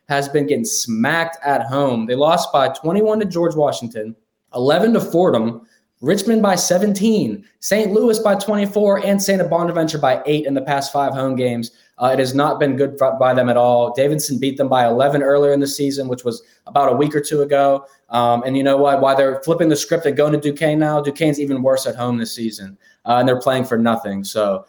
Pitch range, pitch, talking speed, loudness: 130-170 Hz, 140 Hz, 220 wpm, -17 LUFS